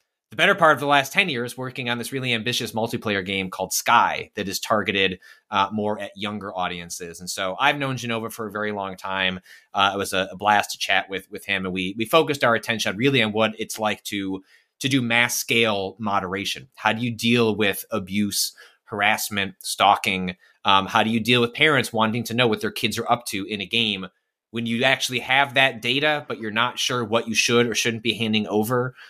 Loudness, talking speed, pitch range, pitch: -22 LUFS, 220 wpm, 100-120 Hz, 115 Hz